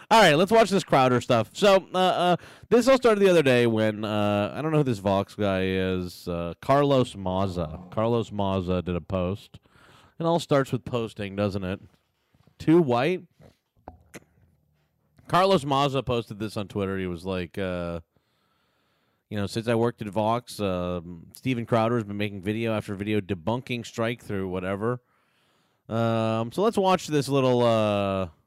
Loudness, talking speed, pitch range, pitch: -25 LUFS, 170 wpm, 95-135 Hz, 110 Hz